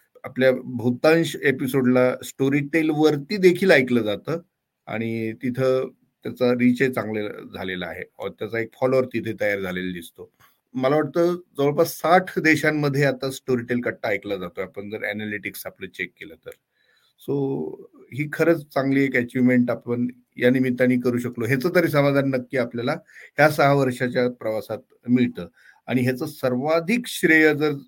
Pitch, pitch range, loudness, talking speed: 130 Hz, 125-150 Hz, -22 LUFS, 140 wpm